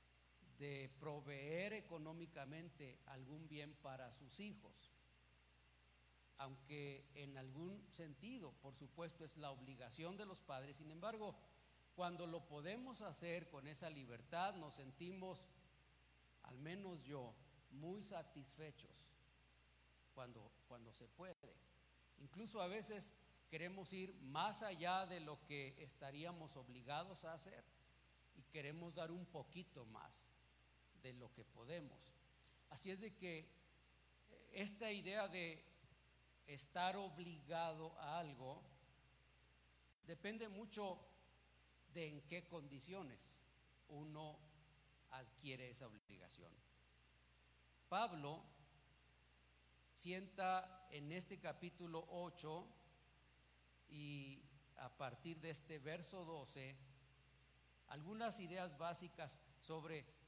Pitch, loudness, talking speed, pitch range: 145 Hz, -52 LUFS, 100 wpm, 115-175 Hz